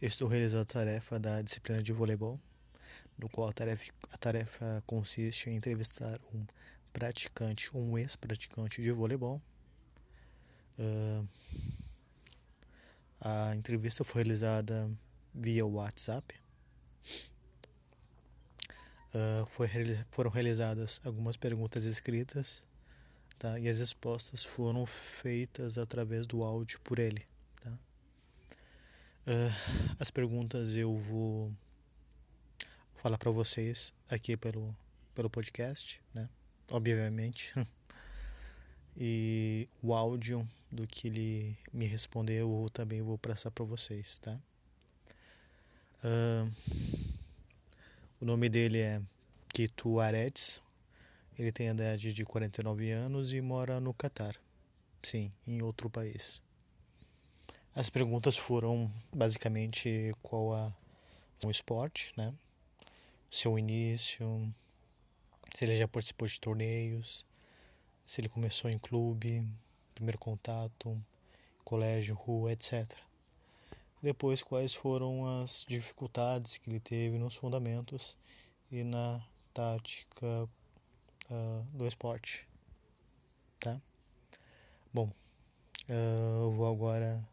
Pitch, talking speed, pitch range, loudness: 115 Hz, 100 wpm, 110-120 Hz, -37 LUFS